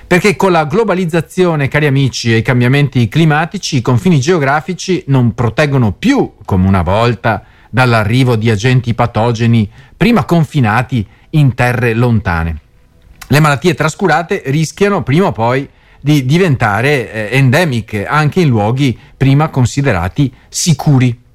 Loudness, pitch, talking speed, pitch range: -12 LUFS, 130 Hz, 125 wpm, 115-155 Hz